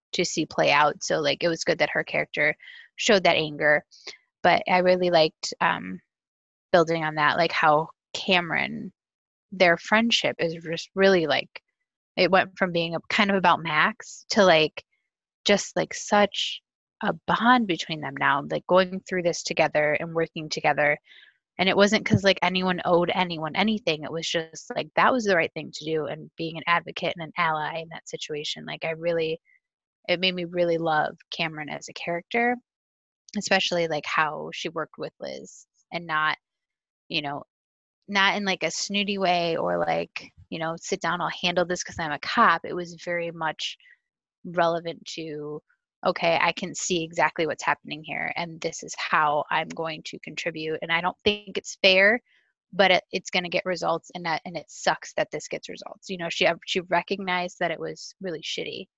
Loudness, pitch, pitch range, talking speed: -24 LUFS, 170 Hz, 160-190 Hz, 190 wpm